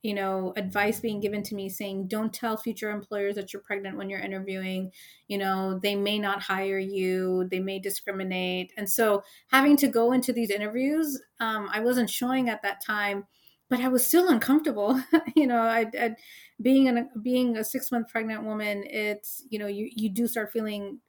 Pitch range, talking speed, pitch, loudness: 200-240 Hz, 195 wpm, 215 Hz, -27 LUFS